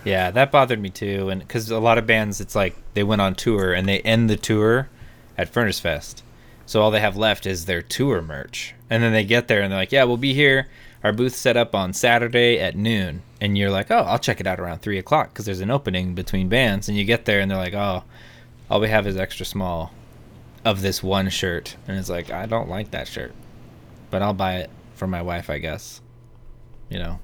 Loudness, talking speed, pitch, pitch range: -21 LUFS, 240 wpm, 105 Hz, 95-115 Hz